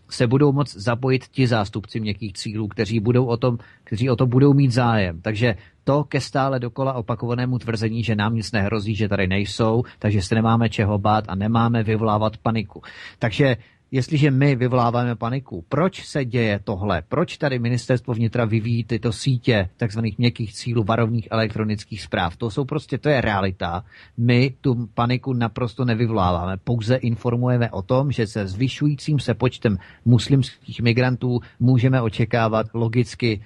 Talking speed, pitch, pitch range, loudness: 160 wpm, 120 Hz, 110-125 Hz, -21 LUFS